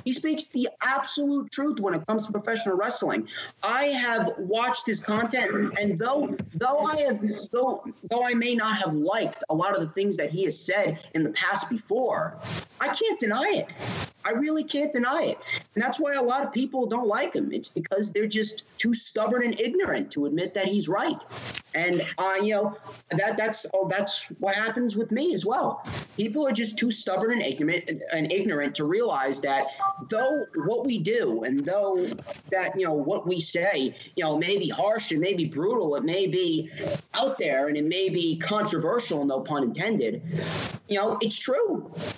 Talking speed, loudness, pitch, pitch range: 190 wpm, -26 LUFS, 215 Hz, 190-255 Hz